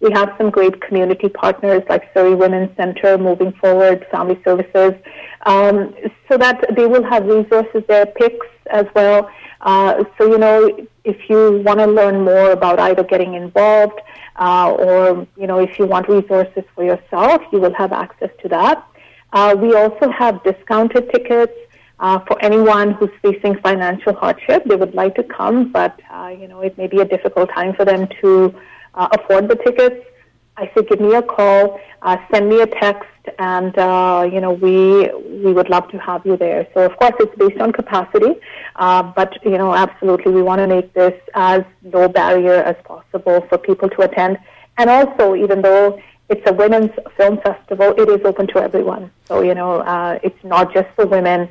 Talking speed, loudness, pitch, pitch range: 190 wpm, -14 LUFS, 195 Hz, 185-210 Hz